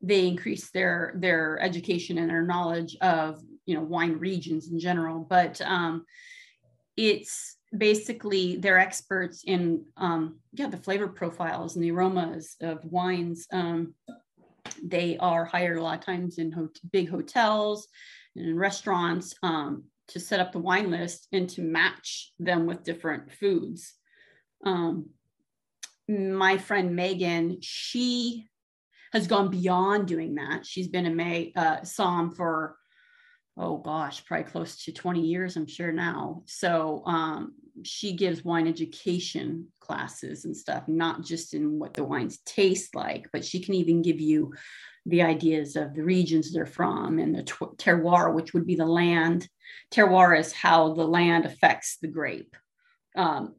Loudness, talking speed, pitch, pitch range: -27 LUFS, 150 wpm, 175 Hz, 165-190 Hz